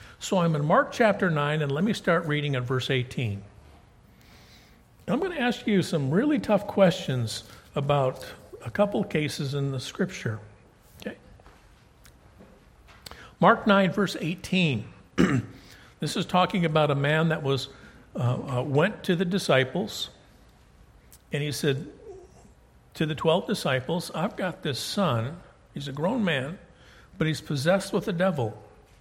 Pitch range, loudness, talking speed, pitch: 130-190 Hz, -26 LUFS, 145 wpm, 155 Hz